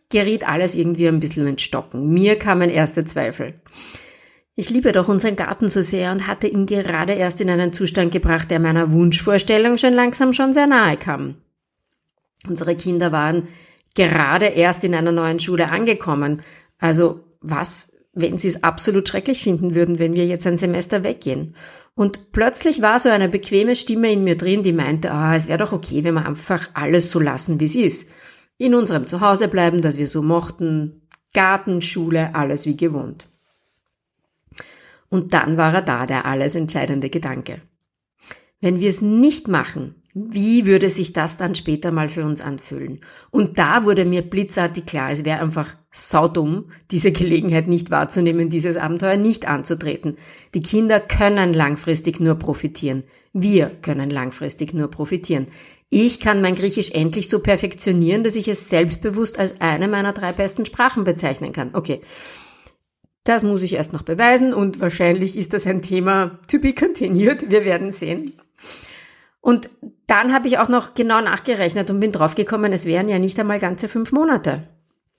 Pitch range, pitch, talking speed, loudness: 160-205 Hz, 180 Hz, 170 wpm, -18 LUFS